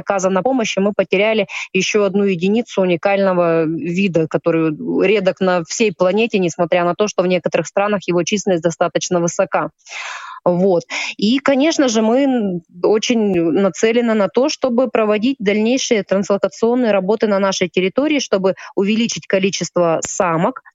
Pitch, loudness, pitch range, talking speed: 195 Hz, -16 LUFS, 180-225 Hz, 135 wpm